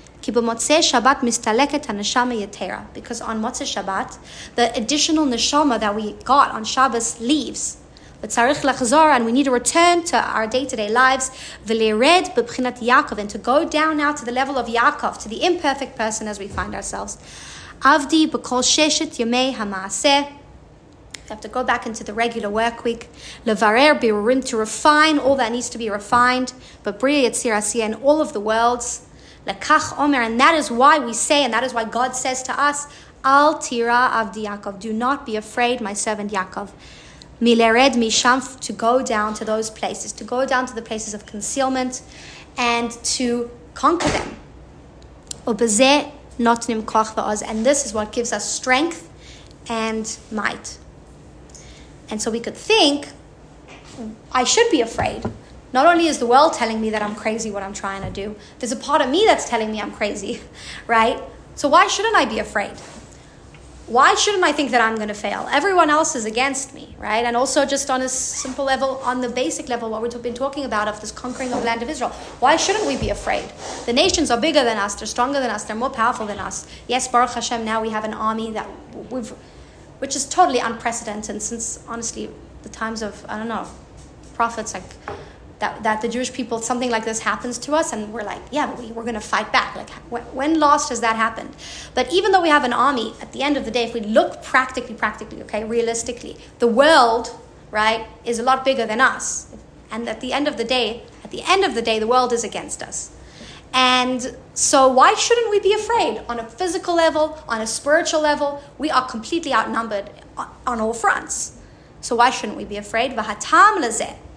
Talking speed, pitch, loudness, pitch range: 185 wpm, 245 Hz, -19 LUFS, 225-275 Hz